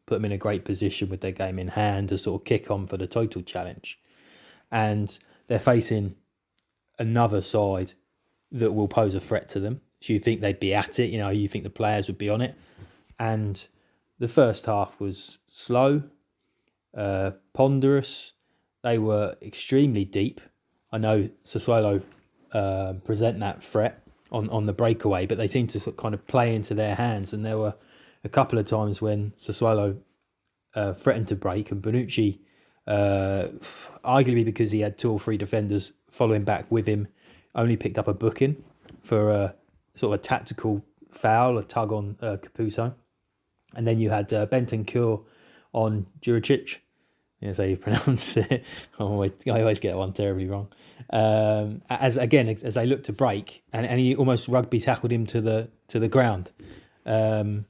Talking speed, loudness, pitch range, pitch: 180 wpm, -26 LUFS, 100-115 Hz, 110 Hz